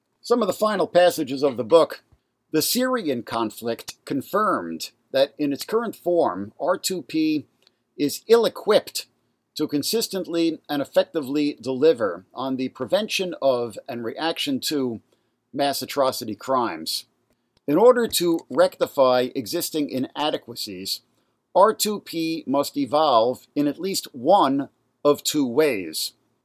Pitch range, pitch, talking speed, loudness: 130-195 Hz, 145 Hz, 120 wpm, -23 LUFS